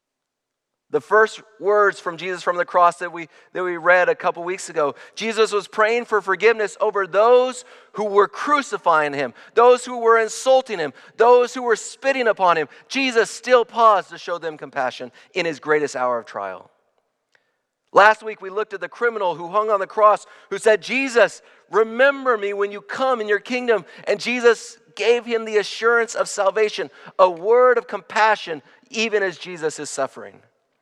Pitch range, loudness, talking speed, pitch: 180-235 Hz, -19 LUFS, 180 wpm, 210 Hz